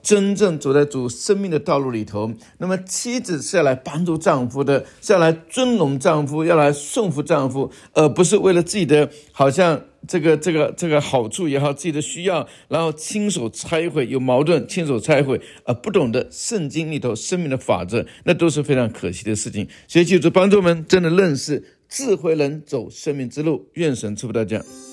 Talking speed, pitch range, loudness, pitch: 295 characters per minute, 135-175 Hz, -19 LUFS, 155 Hz